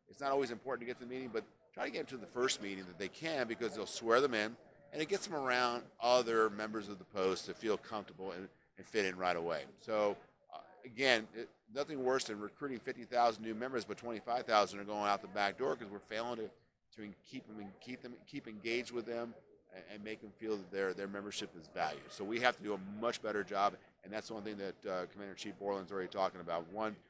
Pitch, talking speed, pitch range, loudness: 110 Hz, 250 wpm, 100-120 Hz, -38 LUFS